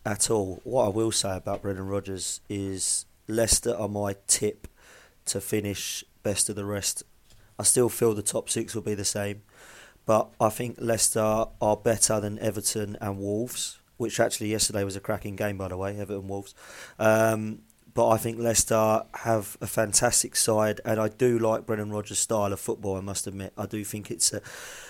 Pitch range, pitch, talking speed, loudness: 100-110 Hz, 105 Hz, 190 wpm, -26 LUFS